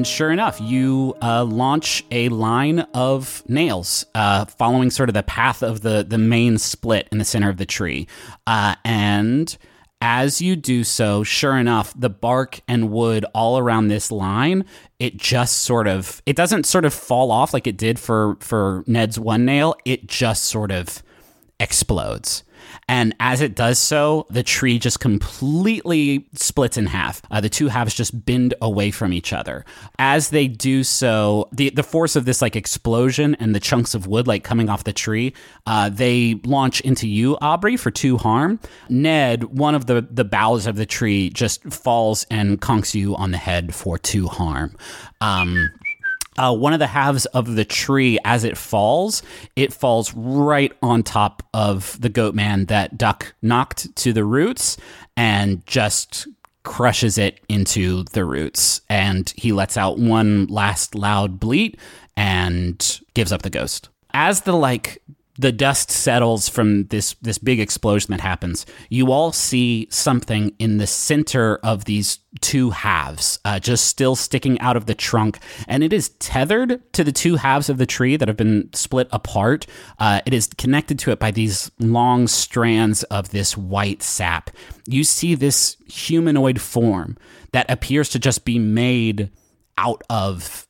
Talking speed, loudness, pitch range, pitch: 170 wpm, -19 LUFS, 105-130 Hz, 115 Hz